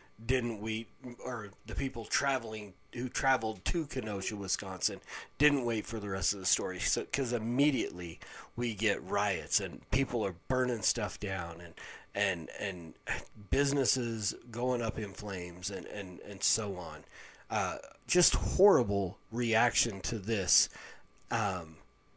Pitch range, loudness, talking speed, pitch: 100-125 Hz, -32 LUFS, 140 wpm, 110 Hz